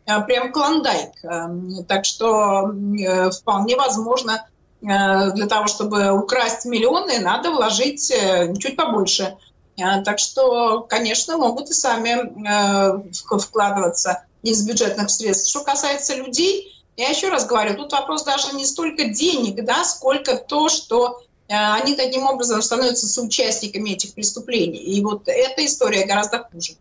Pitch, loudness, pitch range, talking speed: 220 Hz, -19 LUFS, 200-260 Hz, 125 wpm